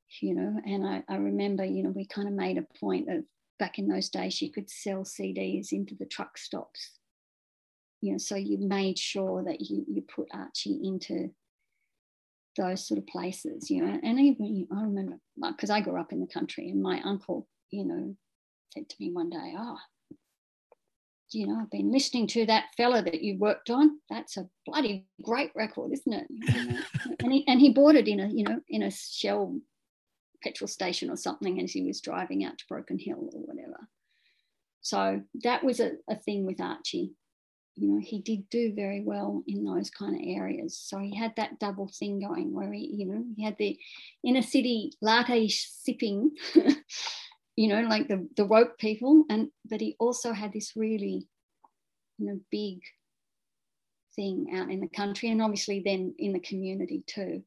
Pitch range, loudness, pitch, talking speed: 190-270 Hz, -30 LUFS, 215 Hz, 190 wpm